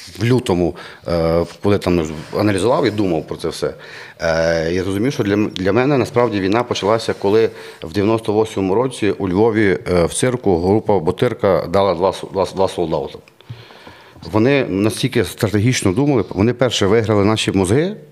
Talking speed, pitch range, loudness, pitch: 135 wpm, 95-120 Hz, -17 LUFS, 105 Hz